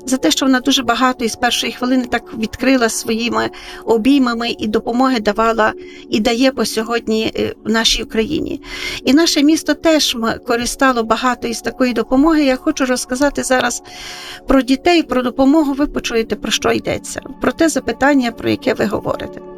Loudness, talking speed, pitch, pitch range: -16 LUFS, 160 wpm, 255 Hz, 230-280 Hz